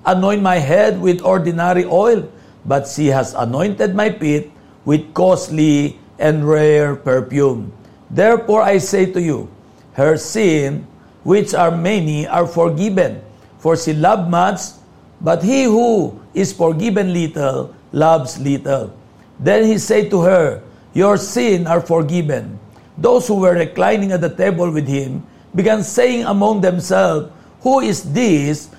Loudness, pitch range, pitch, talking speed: -15 LUFS, 150-195 Hz, 170 Hz, 140 wpm